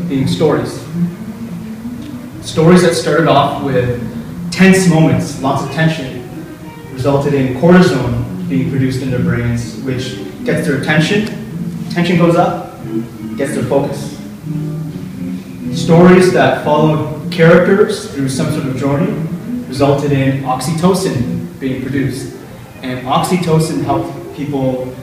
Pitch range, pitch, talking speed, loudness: 130-175 Hz, 155 Hz, 115 wpm, -14 LUFS